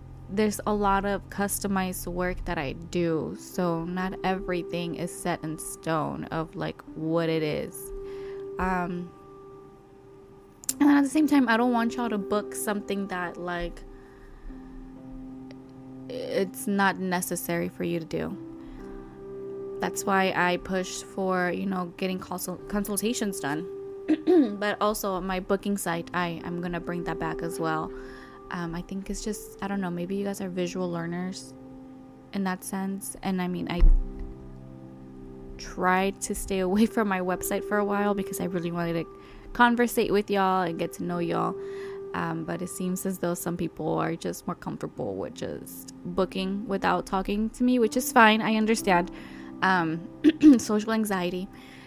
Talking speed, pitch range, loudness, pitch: 160 wpm, 160-200 Hz, -27 LUFS, 185 Hz